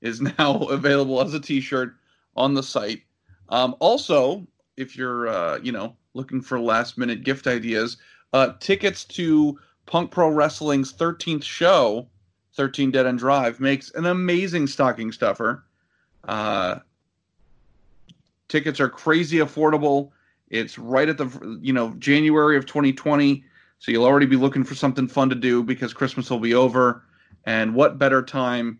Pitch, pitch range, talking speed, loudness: 135 Hz, 120-145 Hz, 150 wpm, -21 LUFS